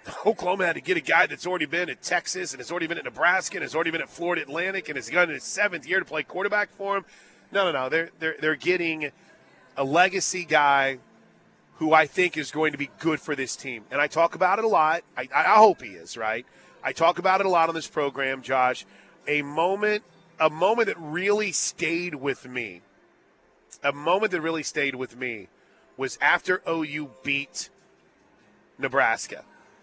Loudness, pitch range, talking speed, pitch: -25 LUFS, 145-180 Hz, 200 wpm, 160 Hz